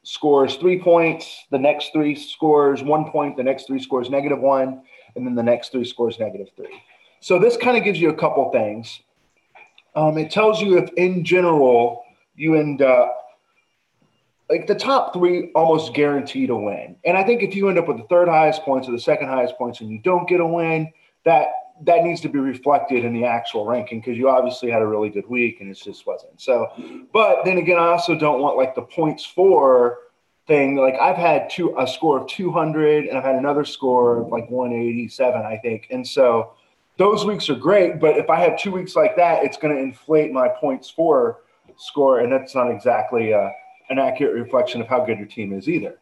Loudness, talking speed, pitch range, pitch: -19 LUFS, 215 wpm, 130-175 Hz, 150 Hz